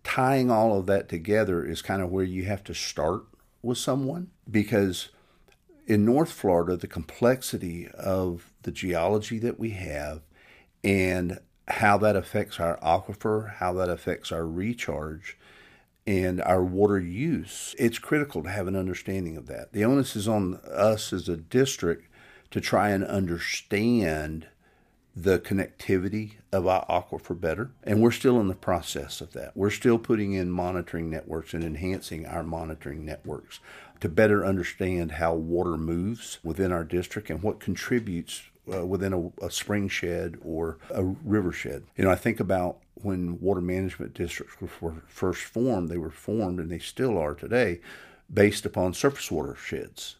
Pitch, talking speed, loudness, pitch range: 95 Hz, 160 wpm, -27 LUFS, 85-105 Hz